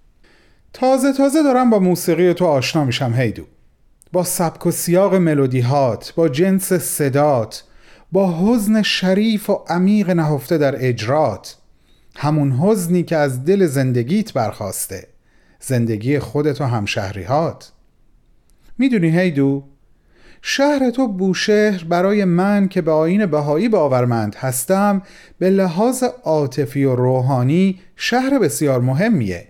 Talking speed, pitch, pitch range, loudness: 120 wpm, 165 Hz, 135-195 Hz, -17 LUFS